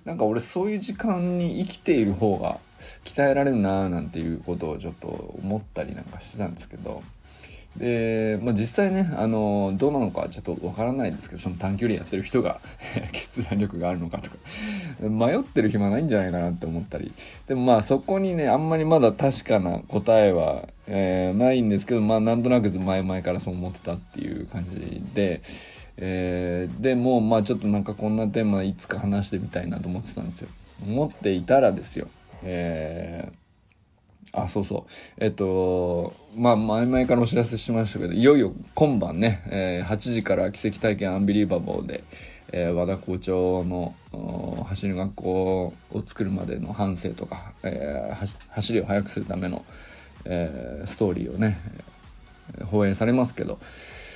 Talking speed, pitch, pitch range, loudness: 360 characters per minute, 105 Hz, 90-115 Hz, -25 LUFS